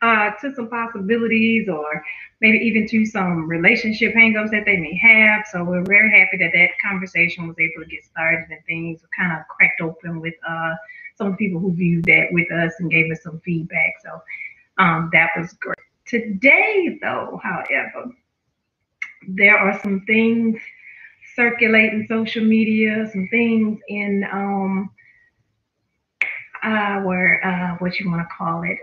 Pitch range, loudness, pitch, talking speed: 170-220 Hz, -17 LUFS, 195 Hz, 155 wpm